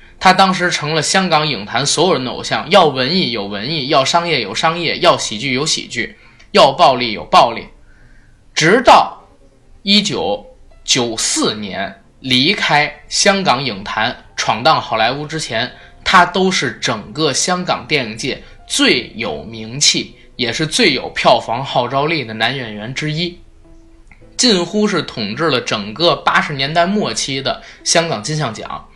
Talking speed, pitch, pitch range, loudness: 225 characters per minute, 155 Hz, 125-175 Hz, -14 LUFS